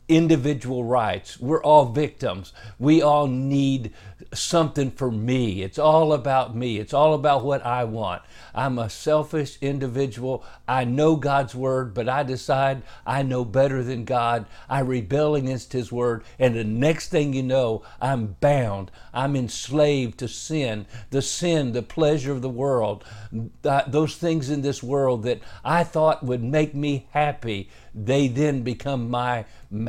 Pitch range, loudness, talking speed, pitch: 120-145 Hz, -23 LUFS, 155 wpm, 130 Hz